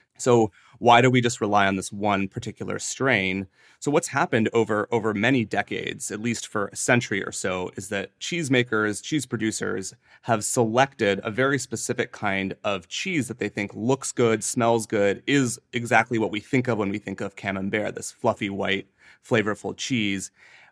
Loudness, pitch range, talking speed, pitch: -24 LUFS, 100-120 Hz, 175 wpm, 110 Hz